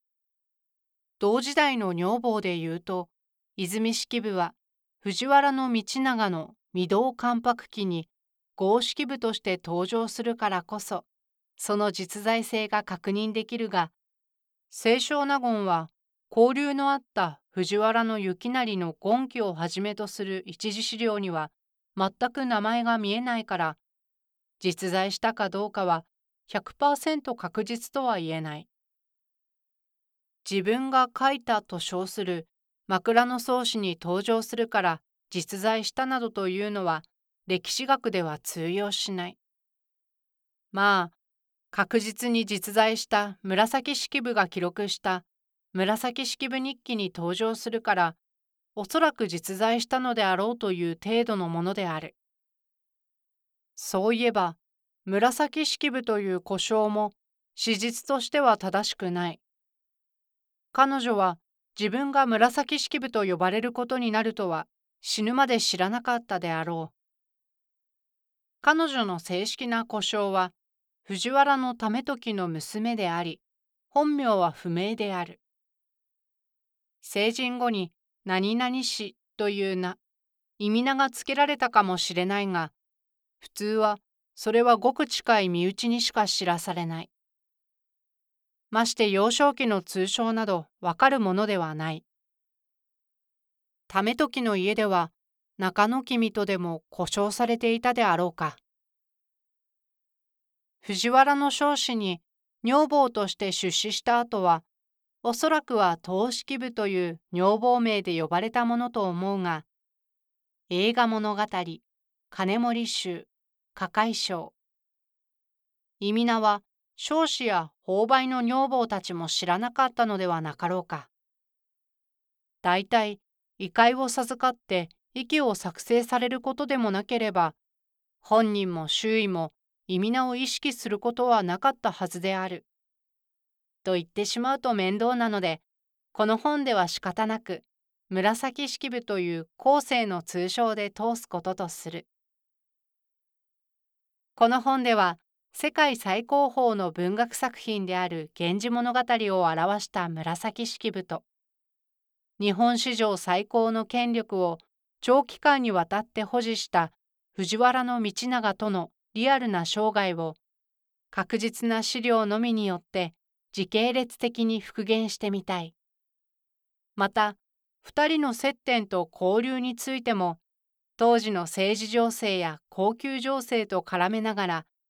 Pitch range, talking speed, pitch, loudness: 185-240 Hz, 235 characters per minute, 215 Hz, -27 LUFS